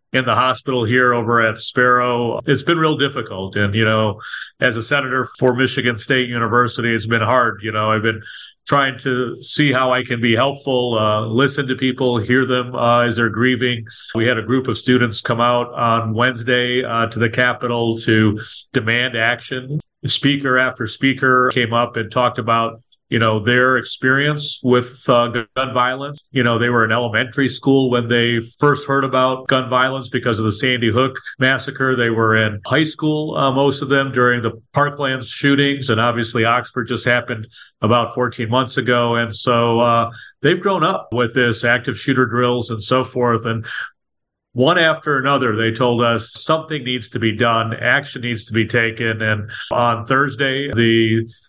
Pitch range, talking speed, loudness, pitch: 115-130 Hz, 180 wpm, -17 LUFS, 125 Hz